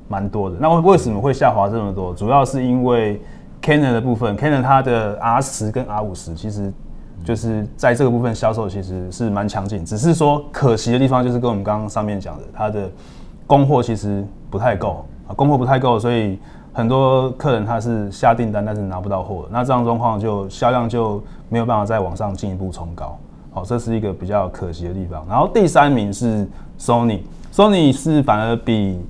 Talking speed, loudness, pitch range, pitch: 330 characters per minute, -18 LUFS, 100-125 Hz, 110 Hz